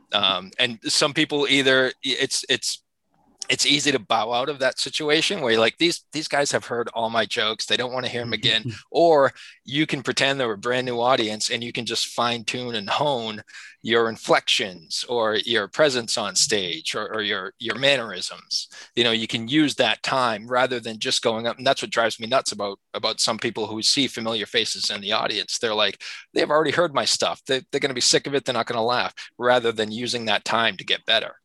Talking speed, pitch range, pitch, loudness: 225 wpm, 115-135 Hz, 125 Hz, -22 LUFS